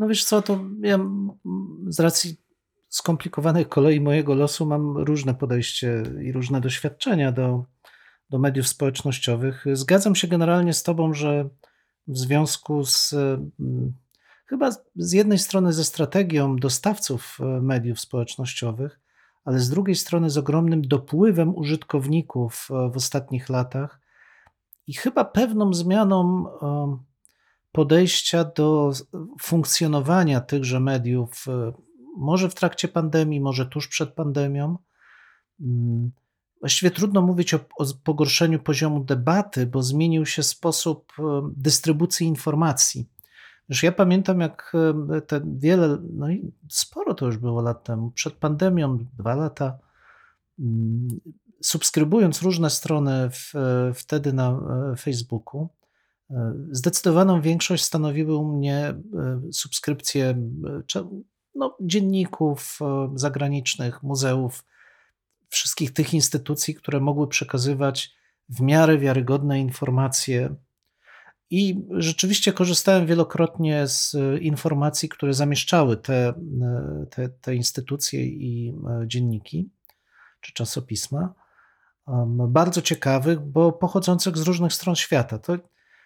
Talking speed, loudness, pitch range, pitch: 105 wpm, -23 LUFS, 130-170 Hz, 150 Hz